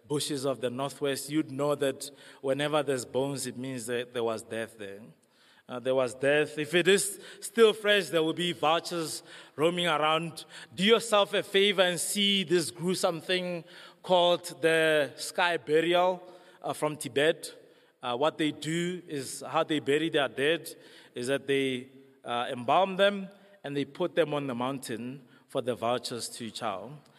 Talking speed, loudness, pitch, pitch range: 170 wpm, -28 LUFS, 150 Hz, 135-175 Hz